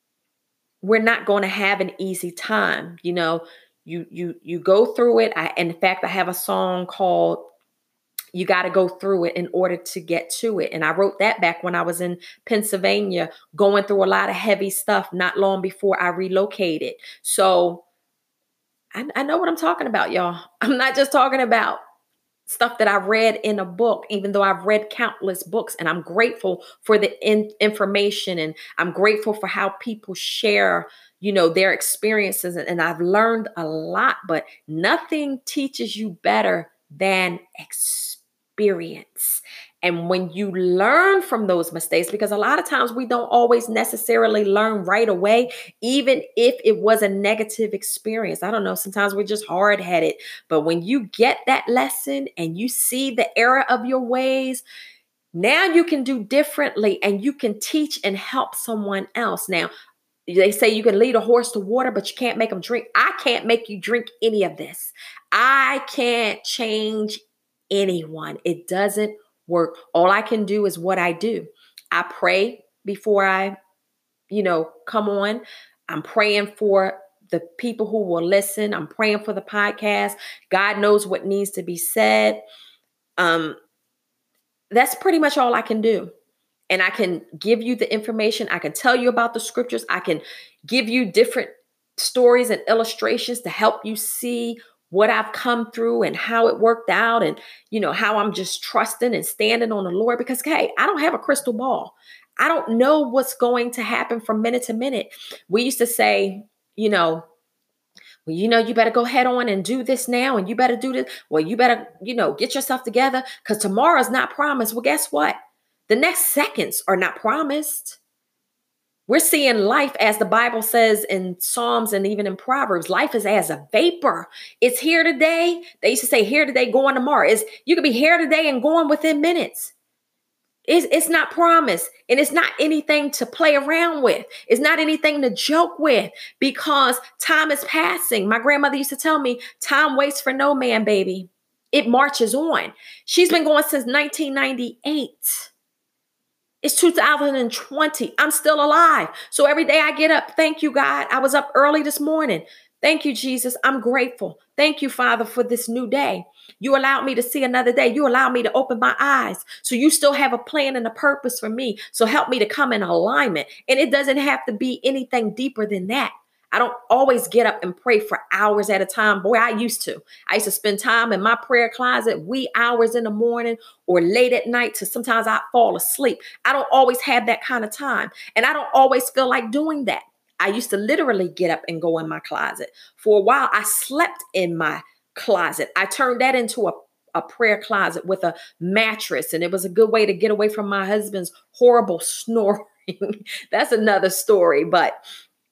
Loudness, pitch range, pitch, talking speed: -19 LUFS, 200-265 Hz, 230 Hz, 190 wpm